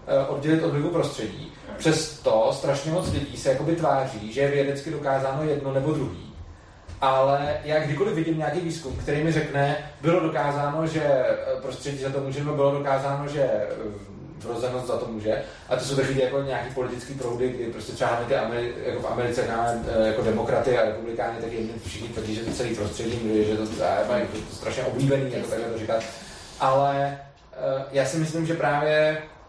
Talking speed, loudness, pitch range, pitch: 180 wpm, -25 LUFS, 115-145 Hz, 135 Hz